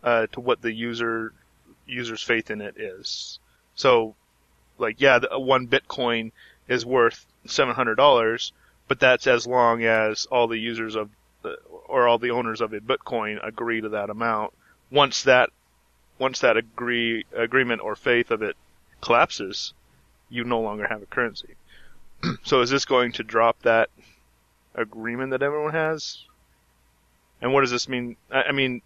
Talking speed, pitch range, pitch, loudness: 160 wpm, 110-125 Hz, 115 Hz, -23 LUFS